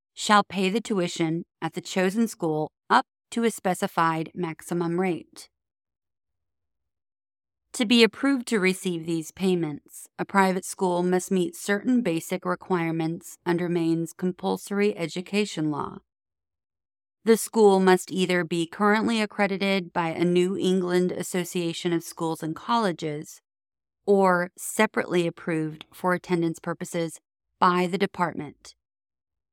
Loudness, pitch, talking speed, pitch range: -25 LUFS, 180 Hz, 120 wpm, 165-195 Hz